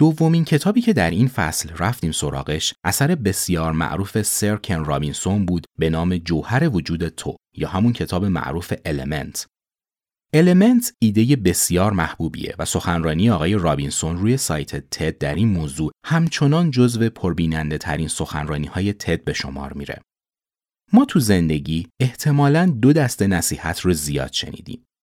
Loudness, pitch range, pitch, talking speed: -20 LUFS, 80-125 Hz, 90 Hz, 140 wpm